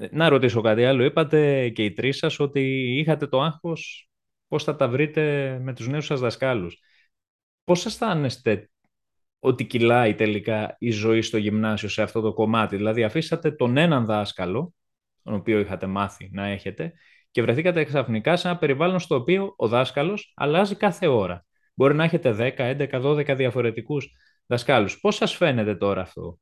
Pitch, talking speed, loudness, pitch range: 130 Hz, 165 wpm, -23 LUFS, 110-155 Hz